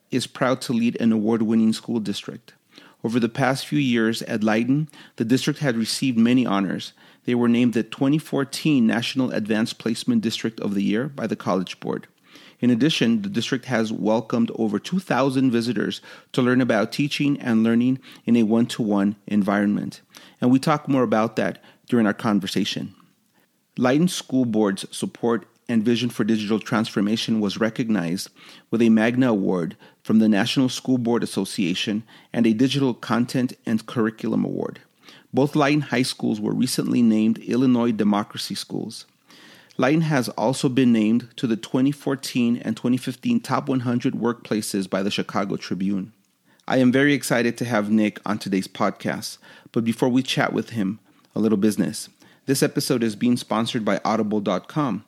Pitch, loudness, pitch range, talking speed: 120 Hz, -22 LUFS, 110-130 Hz, 160 wpm